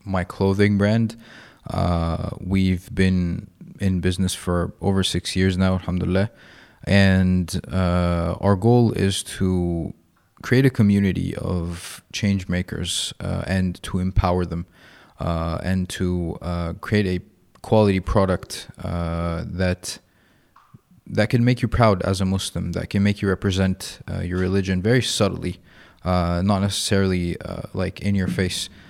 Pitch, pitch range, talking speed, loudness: 95 Hz, 90-100 Hz, 140 wpm, -22 LUFS